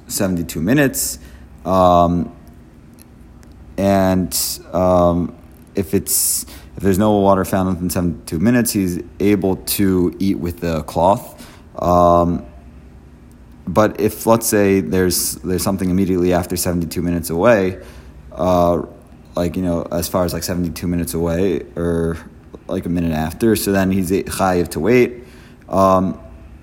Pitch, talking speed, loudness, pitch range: 90 Hz, 130 wpm, -17 LUFS, 80-95 Hz